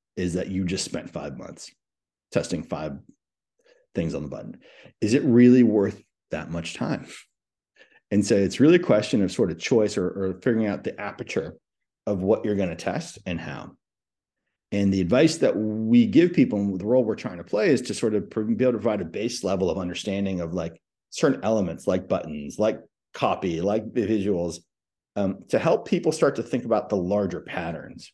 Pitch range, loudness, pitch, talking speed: 90-115 Hz, -24 LUFS, 100 Hz, 195 wpm